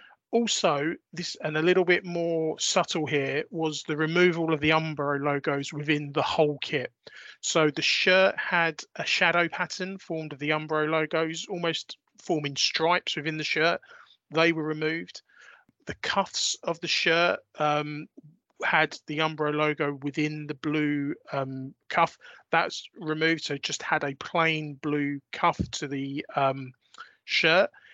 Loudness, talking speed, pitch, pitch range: -26 LUFS, 150 wpm, 155 Hz, 150-170 Hz